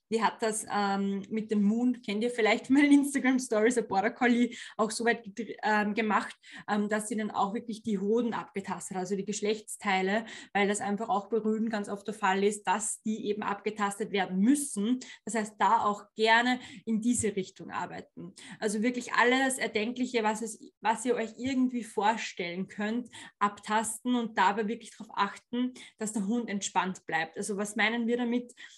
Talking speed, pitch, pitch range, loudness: 180 wpm, 220 Hz, 205-235 Hz, -30 LUFS